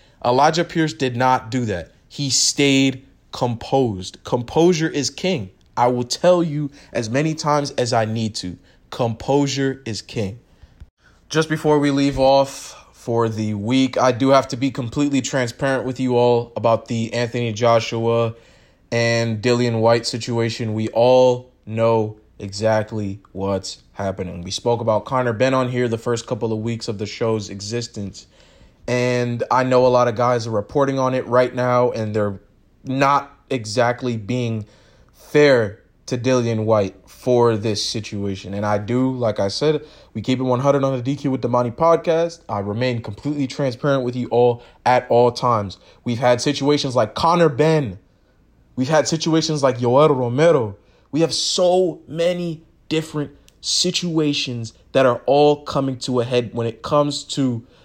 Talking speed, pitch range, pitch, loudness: 160 wpm, 115-140 Hz, 125 Hz, -19 LUFS